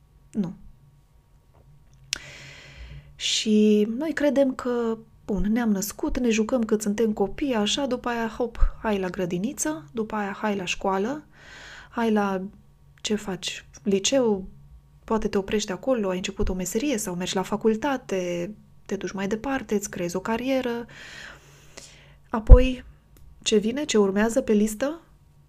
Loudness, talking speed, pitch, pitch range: -25 LUFS, 135 wpm, 215 Hz, 190-240 Hz